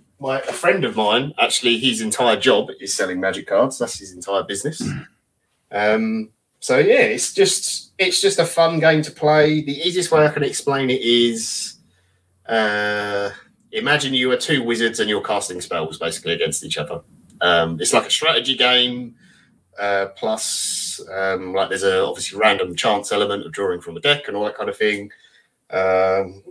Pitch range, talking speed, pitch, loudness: 100-150 Hz, 180 wpm, 120 Hz, -19 LUFS